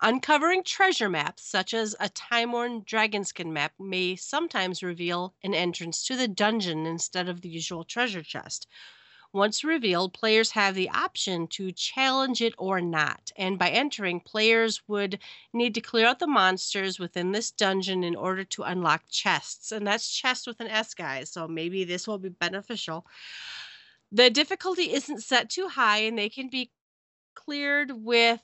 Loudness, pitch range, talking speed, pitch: -26 LUFS, 180-240 Hz, 165 wpm, 205 Hz